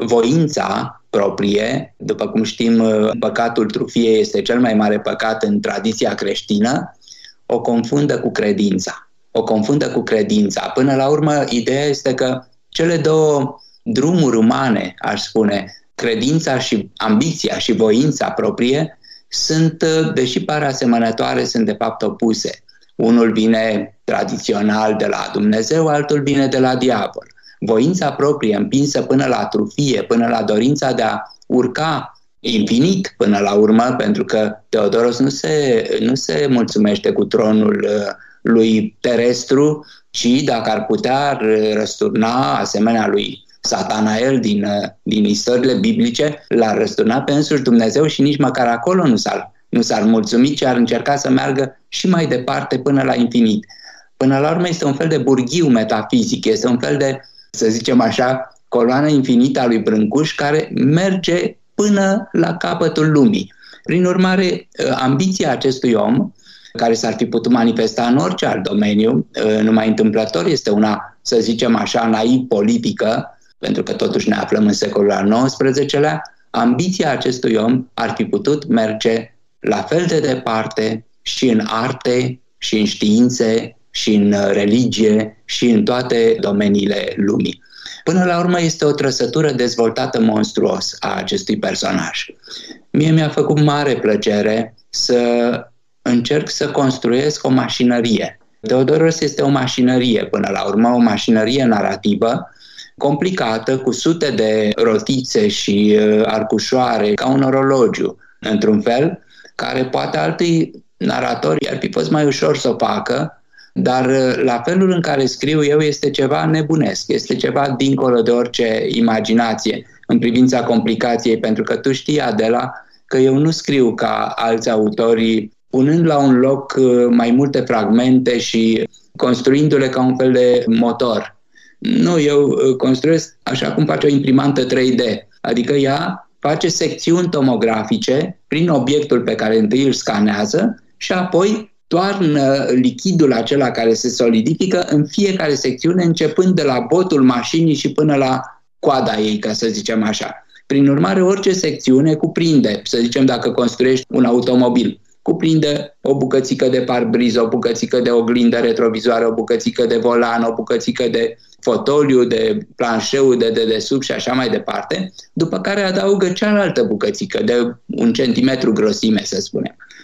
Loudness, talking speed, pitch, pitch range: -16 LUFS, 145 wpm, 130 Hz, 115-150 Hz